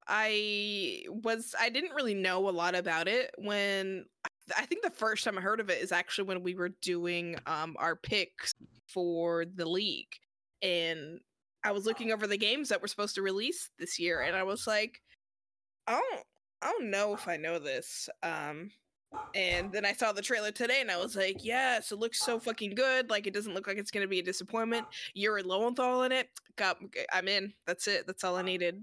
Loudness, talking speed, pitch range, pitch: -33 LUFS, 210 wpm, 185-225 Hz, 200 Hz